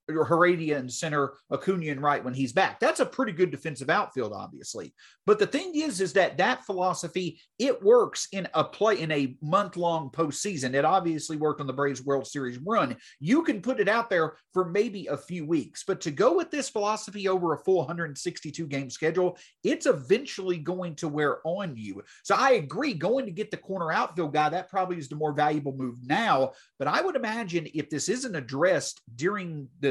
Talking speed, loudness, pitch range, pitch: 205 wpm, -27 LUFS, 150-195 Hz, 170 Hz